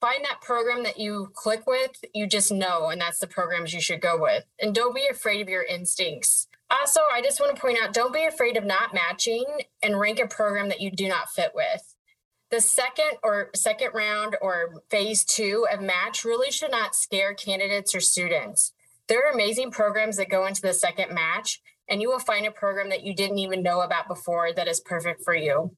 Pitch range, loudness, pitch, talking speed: 185-245 Hz, -24 LUFS, 210 Hz, 215 wpm